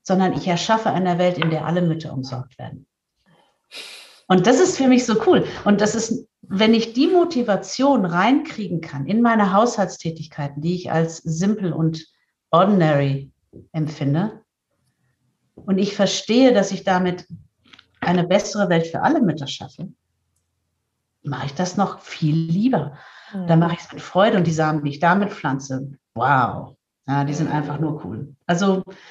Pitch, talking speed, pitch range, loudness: 175 Hz, 160 wpm, 150-205 Hz, -20 LUFS